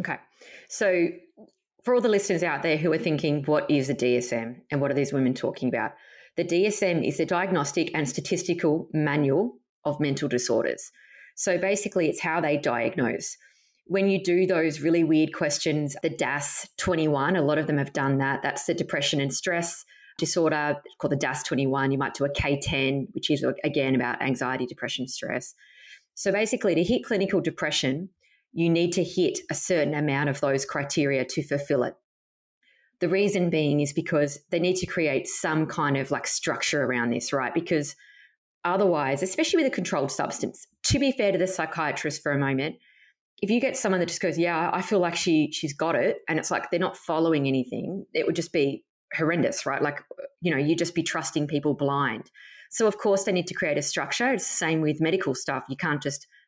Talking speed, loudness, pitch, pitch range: 195 wpm, -26 LUFS, 155 Hz, 140-180 Hz